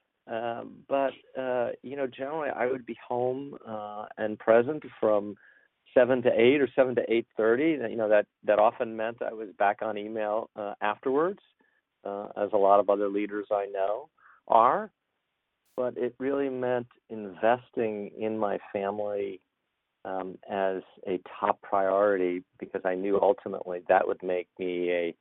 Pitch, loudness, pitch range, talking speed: 105 Hz, -28 LUFS, 100-120 Hz, 160 wpm